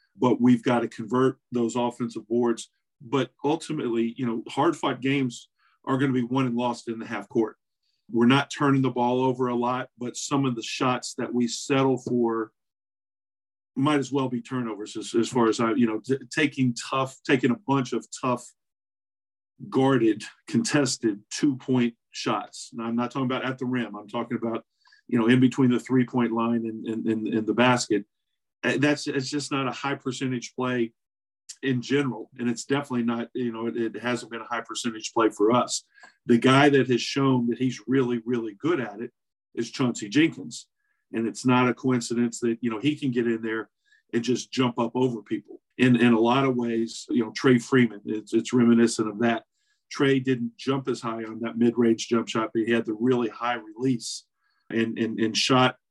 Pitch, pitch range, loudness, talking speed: 120 Hz, 115-130 Hz, -25 LUFS, 195 wpm